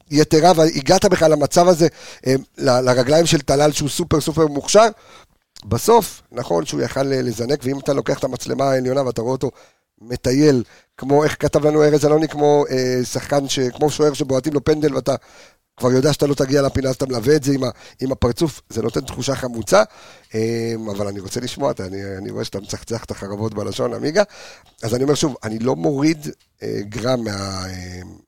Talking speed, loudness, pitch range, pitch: 190 wpm, -18 LUFS, 115-150 Hz, 135 Hz